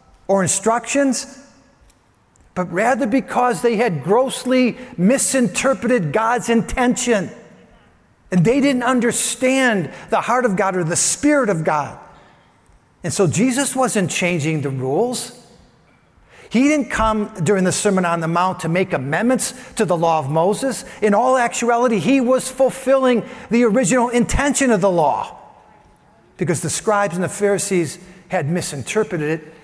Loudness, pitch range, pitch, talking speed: -18 LUFS, 180-250 Hz, 220 Hz, 140 wpm